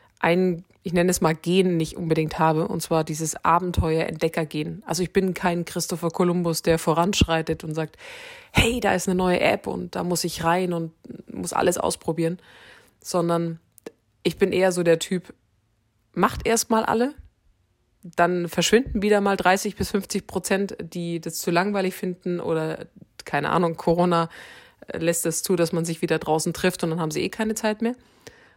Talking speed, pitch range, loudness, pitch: 175 wpm, 165-190 Hz, -23 LUFS, 175 Hz